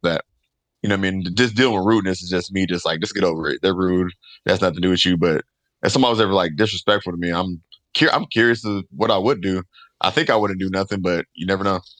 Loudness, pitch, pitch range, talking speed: -20 LUFS, 95 Hz, 90-105 Hz, 275 wpm